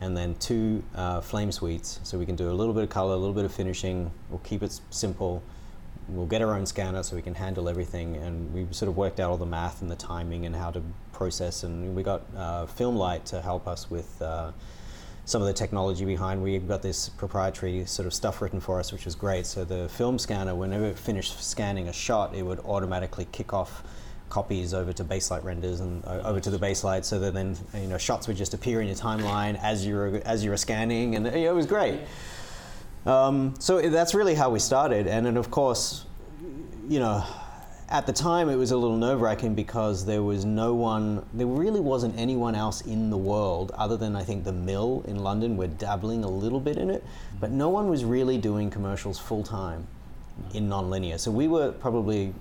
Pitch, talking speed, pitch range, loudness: 100 Hz, 220 wpm, 90-110 Hz, -28 LUFS